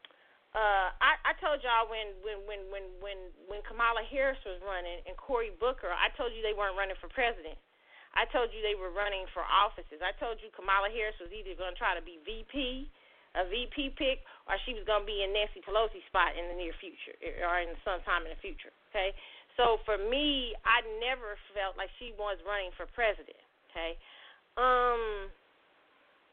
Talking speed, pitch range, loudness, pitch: 195 wpm, 190-235 Hz, -33 LUFS, 210 Hz